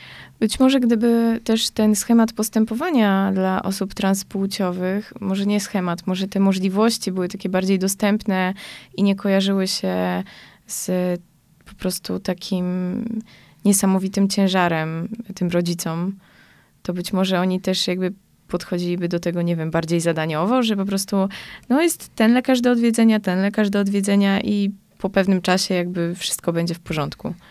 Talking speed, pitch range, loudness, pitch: 145 wpm, 180-210 Hz, -21 LUFS, 195 Hz